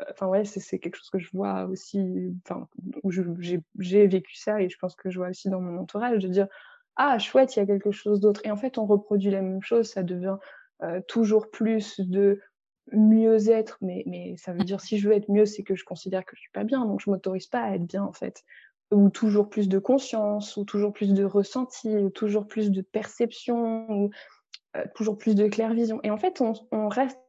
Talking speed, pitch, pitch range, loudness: 240 wpm, 205 Hz, 190-220 Hz, -26 LUFS